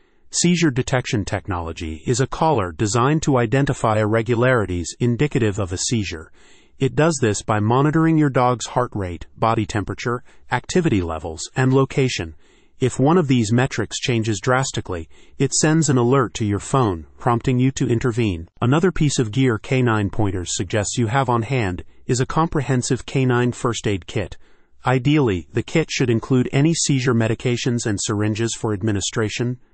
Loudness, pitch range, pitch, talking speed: -20 LUFS, 105-135 Hz, 120 Hz, 155 wpm